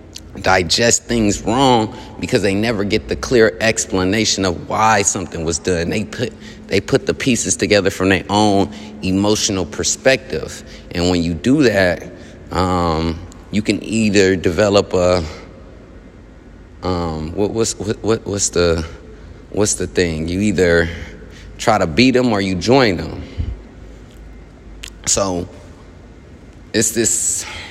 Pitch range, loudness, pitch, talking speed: 85-105 Hz, -16 LUFS, 95 Hz, 130 wpm